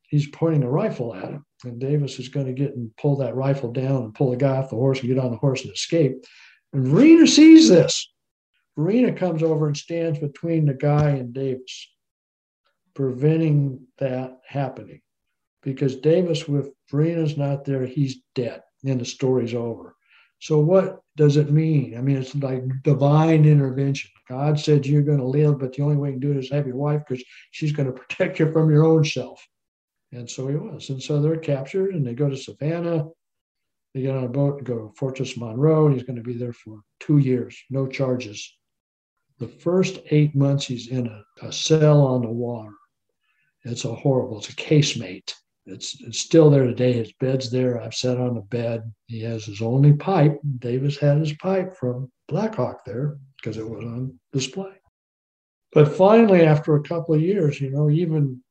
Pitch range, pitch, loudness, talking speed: 125-150 Hz, 140 Hz, -21 LUFS, 195 wpm